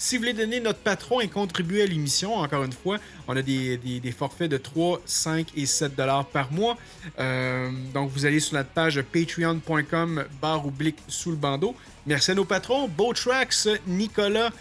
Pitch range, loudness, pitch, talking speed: 140-205 Hz, -25 LUFS, 160 Hz, 190 wpm